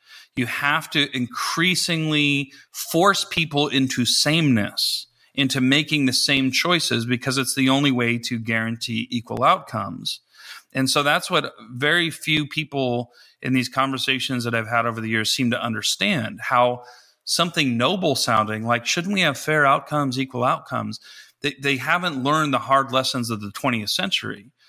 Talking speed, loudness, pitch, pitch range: 155 wpm, -21 LUFS, 130 Hz, 120-145 Hz